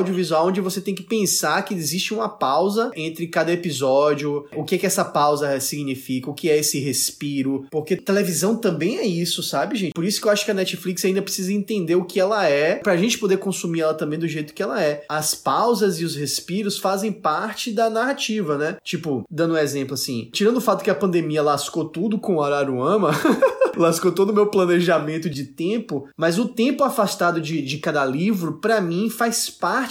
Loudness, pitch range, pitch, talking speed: -21 LUFS, 150-205 Hz, 175 Hz, 205 wpm